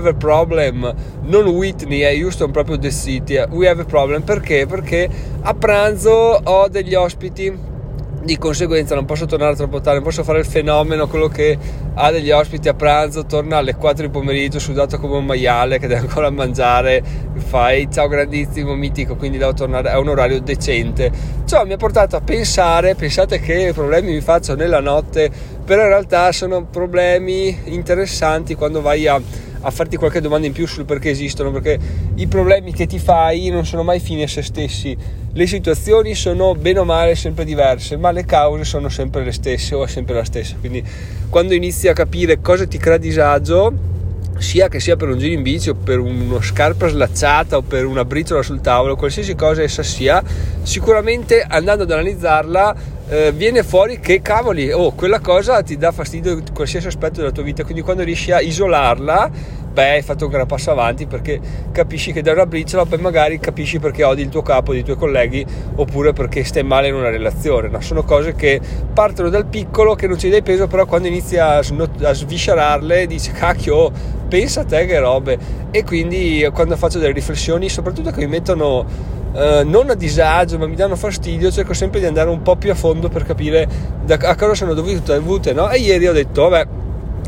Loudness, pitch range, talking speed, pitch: -16 LUFS, 135-175 Hz, 195 wpm, 150 Hz